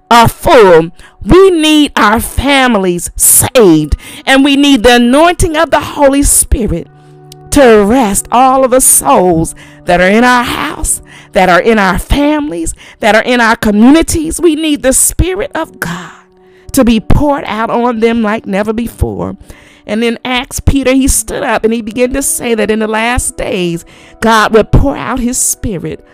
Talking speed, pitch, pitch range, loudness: 170 wpm, 240 Hz, 210-280 Hz, -9 LUFS